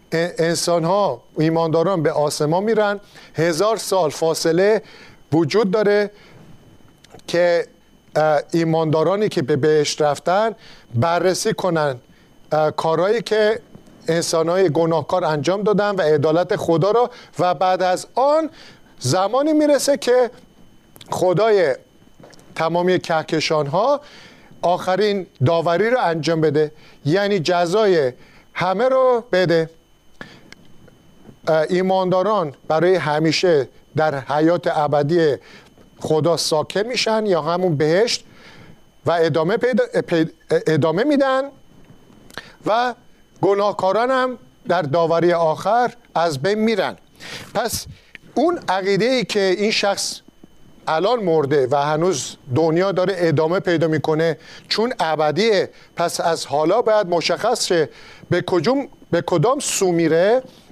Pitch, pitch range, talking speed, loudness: 175 Hz, 160-205 Hz, 105 wpm, -19 LUFS